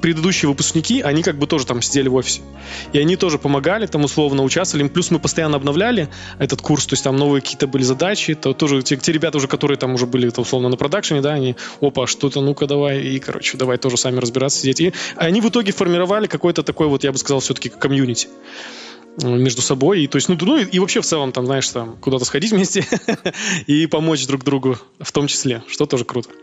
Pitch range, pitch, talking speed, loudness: 130-165 Hz, 145 Hz, 225 wpm, -18 LUFS